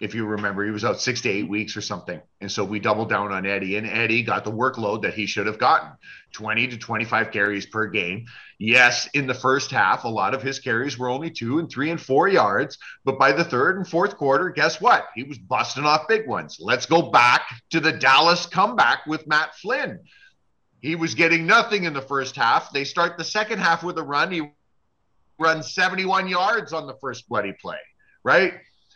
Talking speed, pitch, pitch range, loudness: 215 wpm, 135 Hz, 110-165 Hz, -21 LUFS